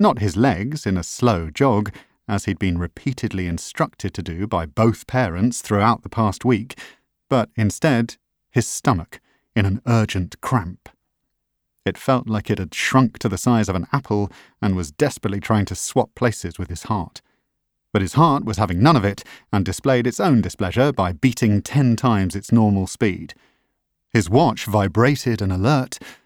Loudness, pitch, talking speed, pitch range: -20 LUFS, 110 Hz, 175 wpm, 95-125 Hz